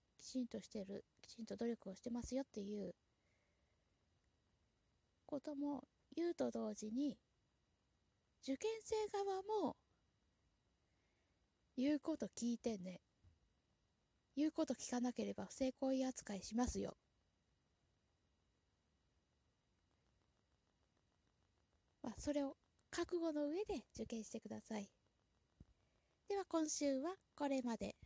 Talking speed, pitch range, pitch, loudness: 195 characters per minute, 210-295 Hz, 255 Hz, -45 LUFS